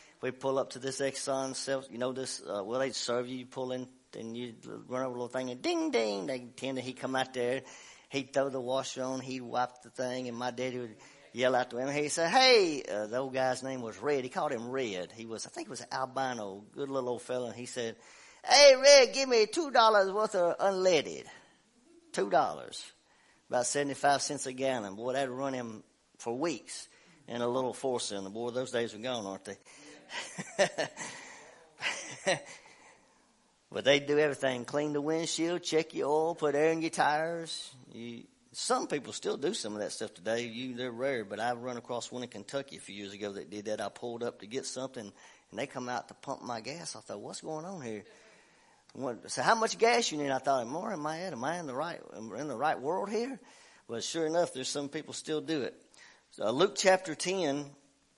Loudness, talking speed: -32 LUFS, 225 wpm